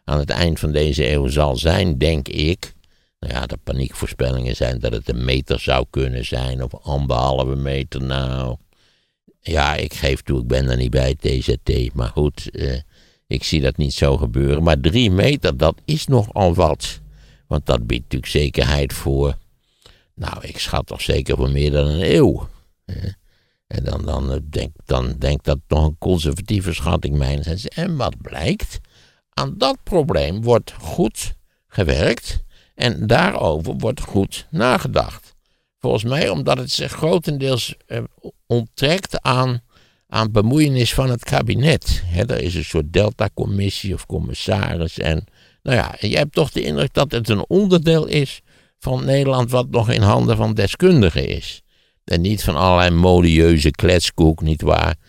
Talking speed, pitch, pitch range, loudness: 160 wpm, 80 Hz, 70-105 Hz, -19 LUFS